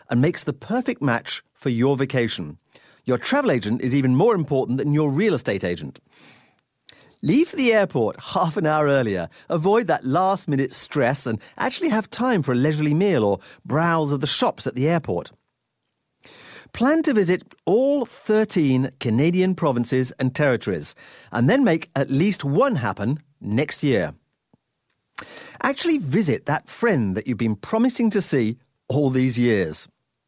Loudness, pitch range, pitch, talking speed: -22 LUFS, 130-200 Hz, 145 Hz, 160 wpm